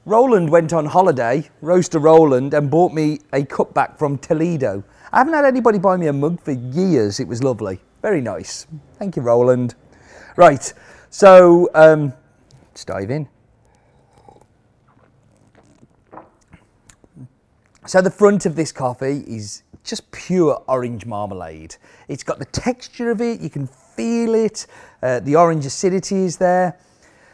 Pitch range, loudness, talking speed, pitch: 125-185 Hz, -16 LUFS, 145 wpm, 155 Hz